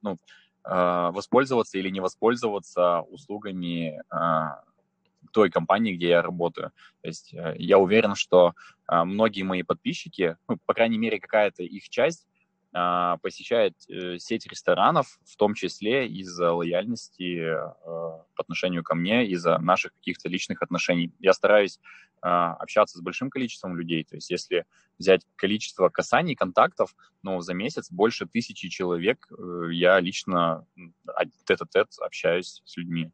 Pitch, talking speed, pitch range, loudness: 90 Hz, 140 wpm, 85-100 Hz, -25 LUFS